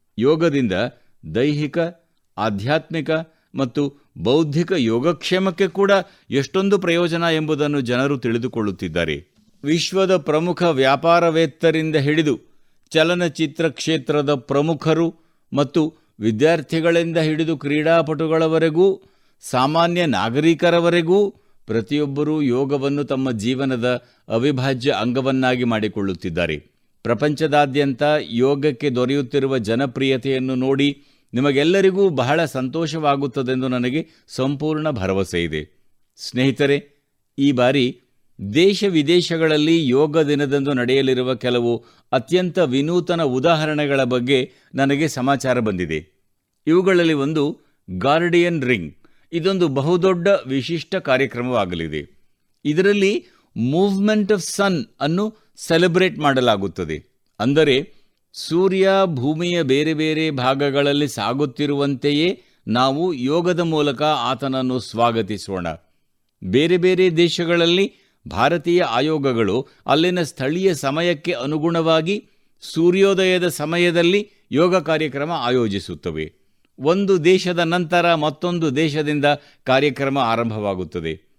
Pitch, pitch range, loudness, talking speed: 150 Hz, 130-170 Hz, -19 LUFS, 80 wpm